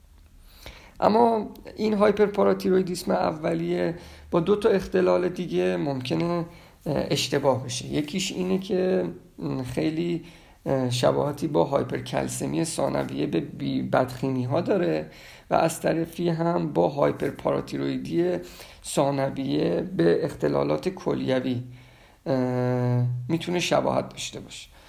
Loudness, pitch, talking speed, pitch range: -25 LUFS, 150 Hz, 95 wpm, 125-175 Hz